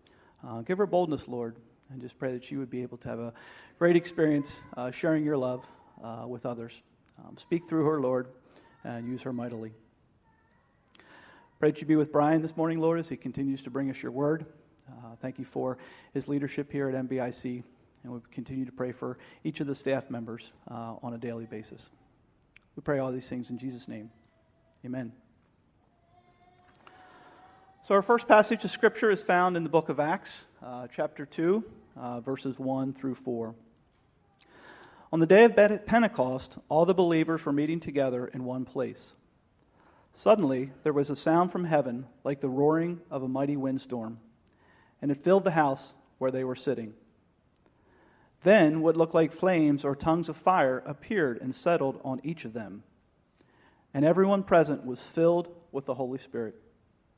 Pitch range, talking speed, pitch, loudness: 125-160 Hz, 175 wpm, 135 Hz, -28 LUFS